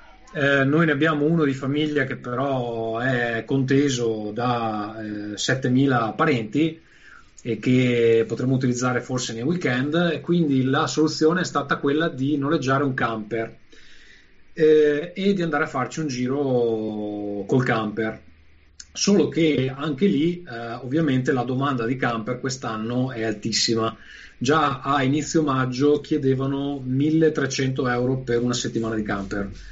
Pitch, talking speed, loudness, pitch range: 130 Hz, 135 wpm, -22 LUFS, 115-150 Hz